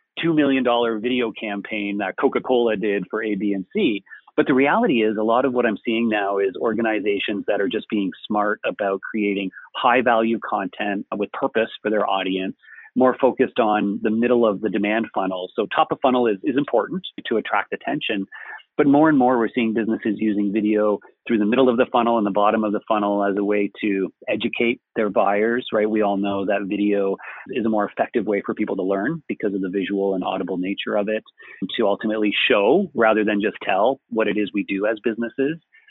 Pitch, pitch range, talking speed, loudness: 110 Hz, 100-120 Hz, 210 wpm, -21 LUFS